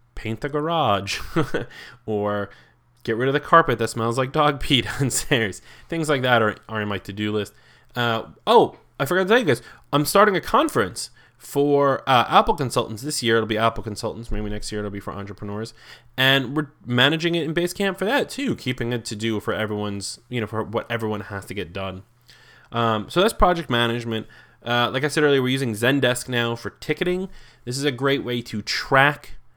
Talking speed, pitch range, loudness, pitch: 205 wpm, 110-140 Hz, -22 LUFS, 120 Hz